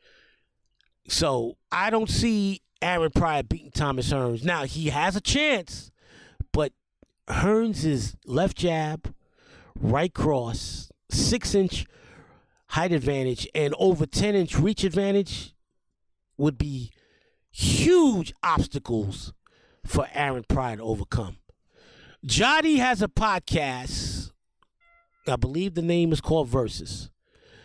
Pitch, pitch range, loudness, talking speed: 160 Hz, 130-200 Hz, -25 LUFS, 110 wpm